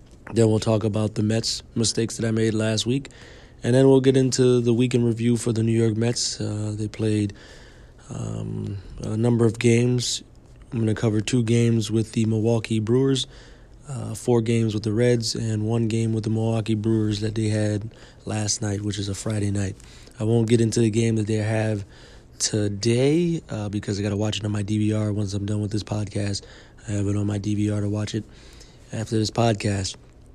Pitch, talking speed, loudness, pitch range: 110 Hz, 210 wpm, -23 LUFS, 105-120 Hz